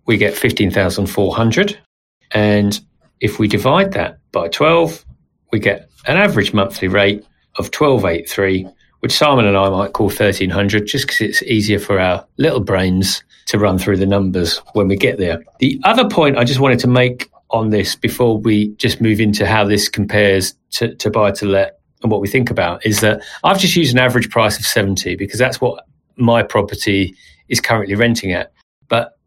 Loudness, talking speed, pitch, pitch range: -15 LUFS, 185 wpm, 105 Hz, 100-120 Hz